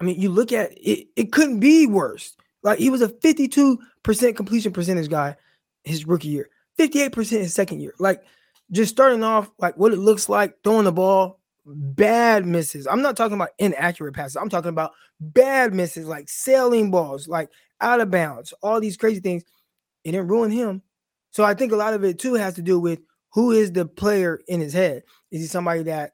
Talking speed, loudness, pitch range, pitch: 205 wpm, -20 LUFS, 175-225 Hz, 195 Hz